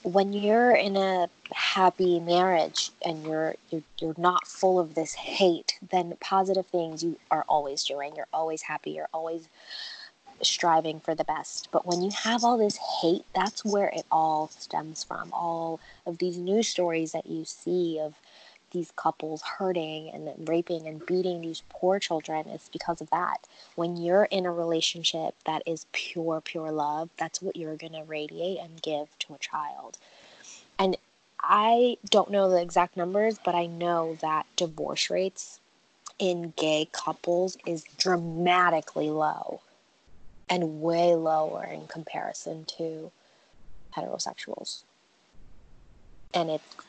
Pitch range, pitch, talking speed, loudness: 160-185 Hz, 170 Hz, 150 wpm, -28 LUFS